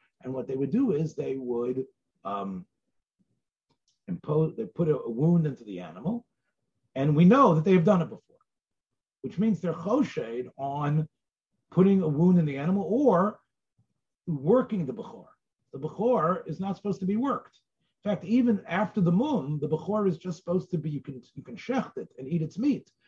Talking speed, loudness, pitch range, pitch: 185 wpm, -27 LUFS, 140-205 Hz, 170 Hz